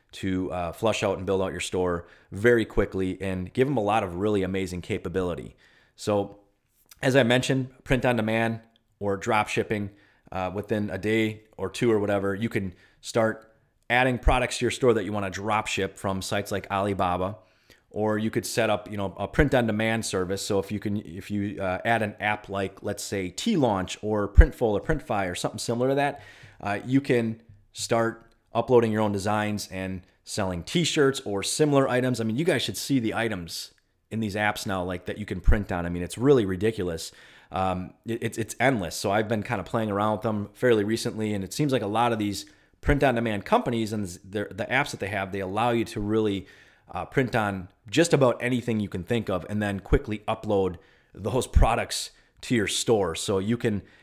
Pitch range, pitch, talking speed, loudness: 95-115 Hz, 105 Hz, 210 wpm, -26 LUFS